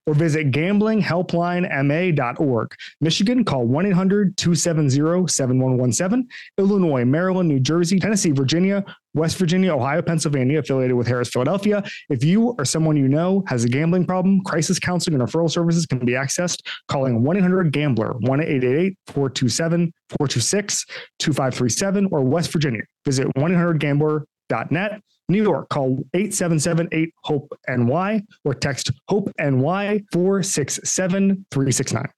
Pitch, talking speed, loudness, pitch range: 160 Hz, 125 wpm, -20 LUFS, 135-185 Hz